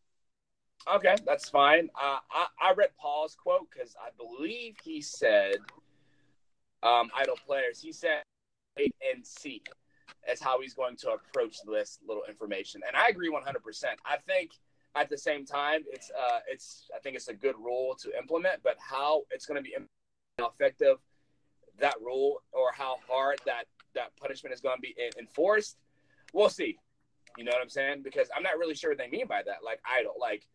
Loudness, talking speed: -31 LUFS, 185 wpm